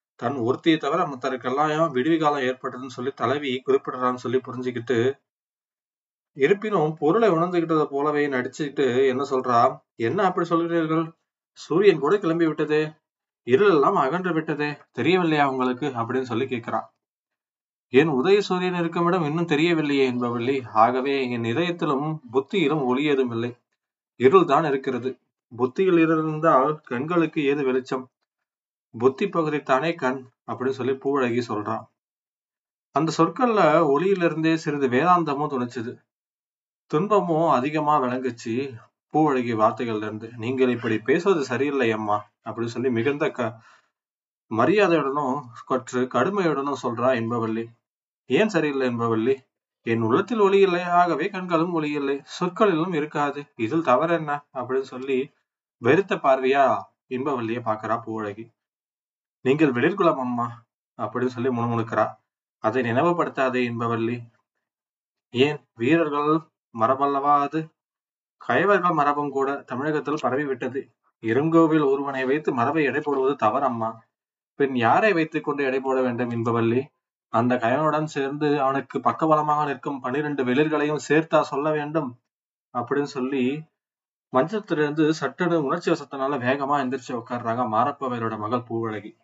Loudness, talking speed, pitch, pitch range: -23 LUFS, 115 wpm, 140 Hz, 125-155 Hz